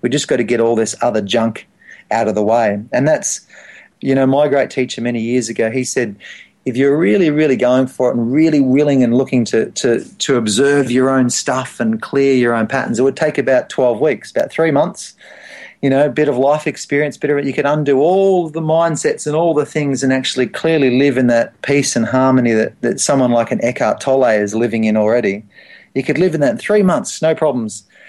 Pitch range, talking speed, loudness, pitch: 120-150 Hz, 230 wpm, -15 LUFS, 135 Hz